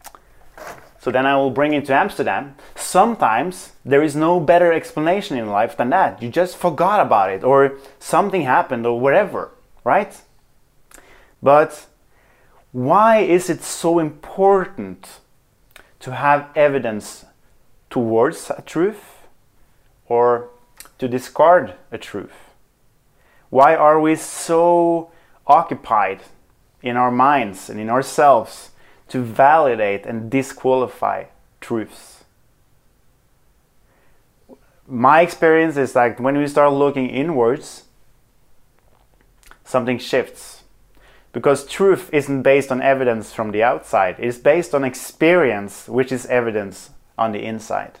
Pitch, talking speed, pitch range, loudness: 135 Hz, 115 wpm, 125-155 Hz, -17 LUFS